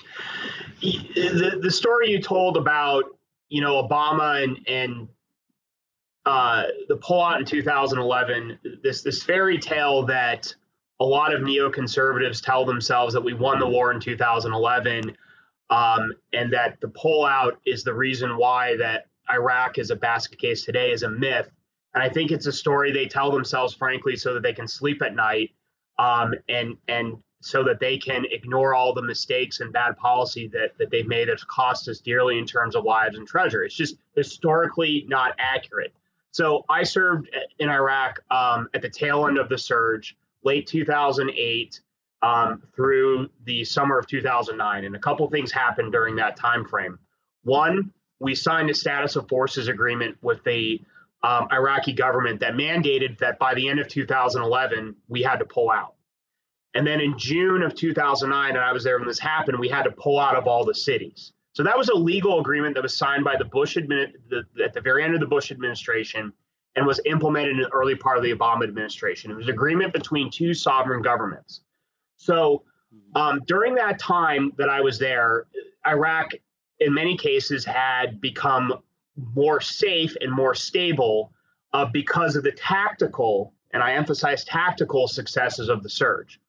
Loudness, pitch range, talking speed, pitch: -23 LUFS, 125-160 Hz, 180 wpm, 140 Hz